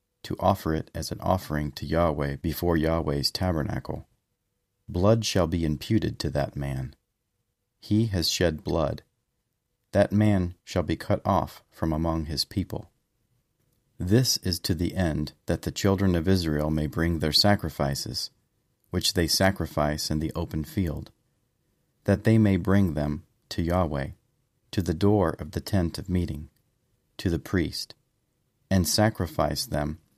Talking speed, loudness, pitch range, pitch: 145 wpm, -26 LUFS, 75-100 Hz, 85 Hz